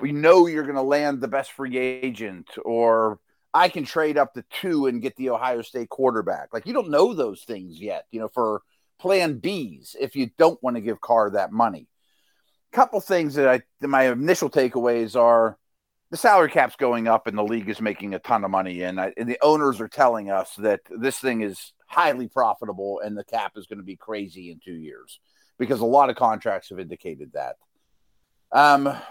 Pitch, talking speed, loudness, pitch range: 120 Hz, 210 wpm, -22 LUFS, 105-135 Hz